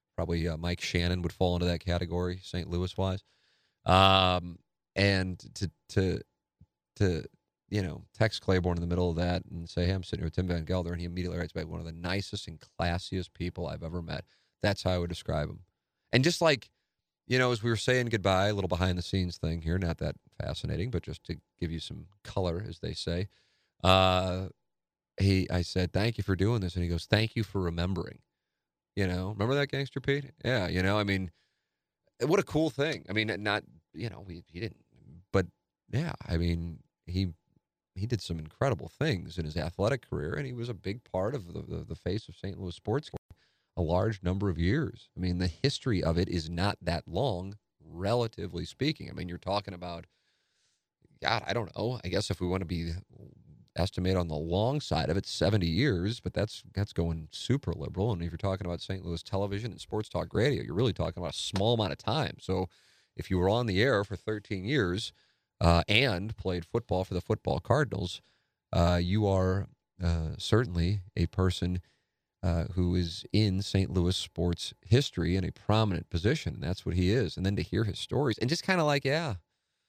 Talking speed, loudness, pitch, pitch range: 210 wpm, -31 LUFS, 95 Hz, 85-105 Hz